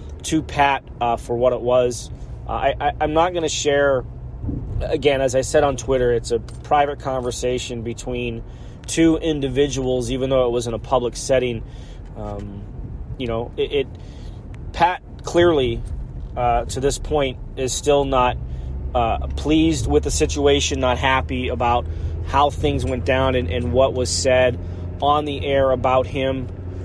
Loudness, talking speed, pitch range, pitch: -20 LUFS, 160 wpm, 115-135 Hz, 125 Hz